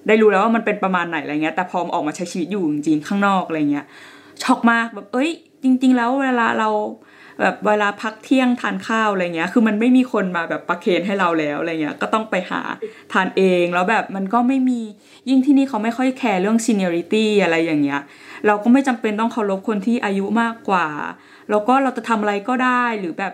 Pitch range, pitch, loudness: 185-245 Hz, 215 Hz, -19 LUFS